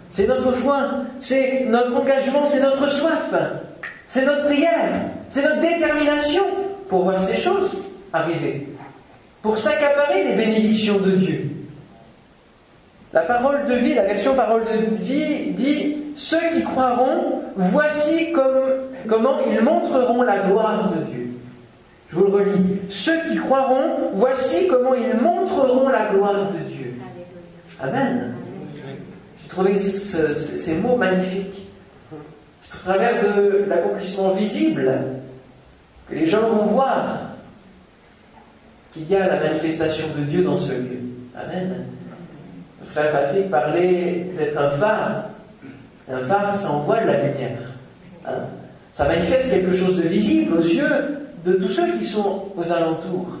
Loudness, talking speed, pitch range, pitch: -20 LUFS, 135 wpm, 170-270 Hz, 200 Hz